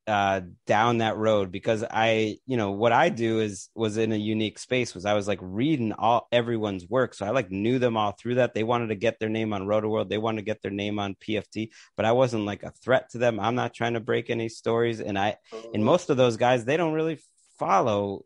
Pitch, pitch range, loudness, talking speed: 110 Hz, 105-120 Hz, -26 LUFS, 250 wpm